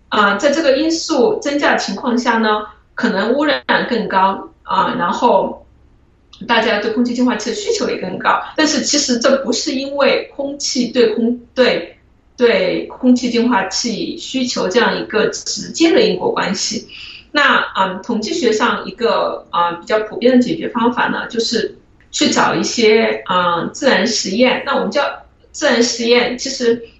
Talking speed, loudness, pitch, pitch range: 255 characters per minute, -15 LUFS, 240 Hz, 220-275 Hz